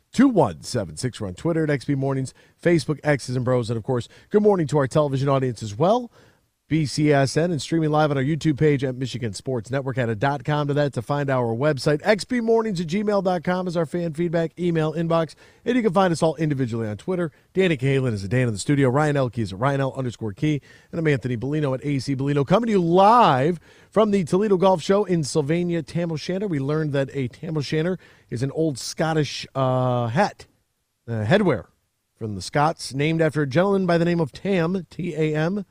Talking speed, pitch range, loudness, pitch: 210 wpm, 130-170 Hz, -22 LUFS, 150 Hz